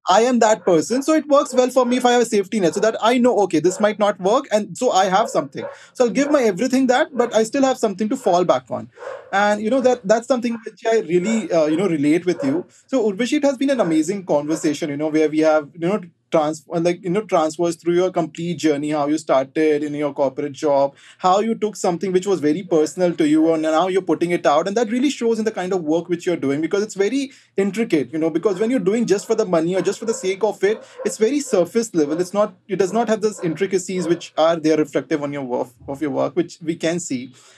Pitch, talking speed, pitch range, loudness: 195 Hz, 265 wpm, 165-230 Hz, -19 LUFS